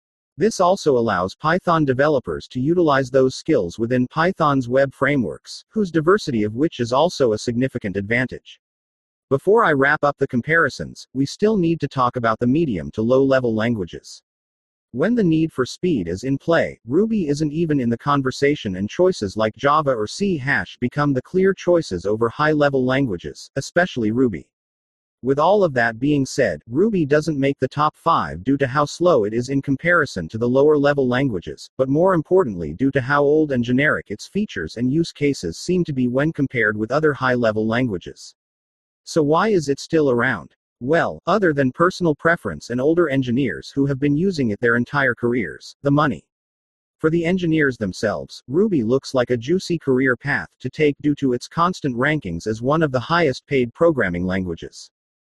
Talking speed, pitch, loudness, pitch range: 185 wpm, 135 Hz, -20 LUFS, 120-160 Hz